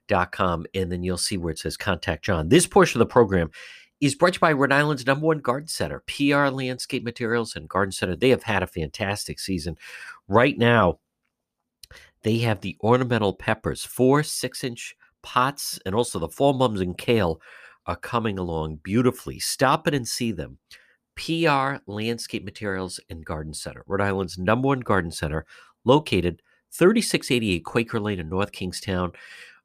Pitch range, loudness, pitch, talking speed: 90-130 Hz, -23 LUFS, 110 Hz, 170 wpm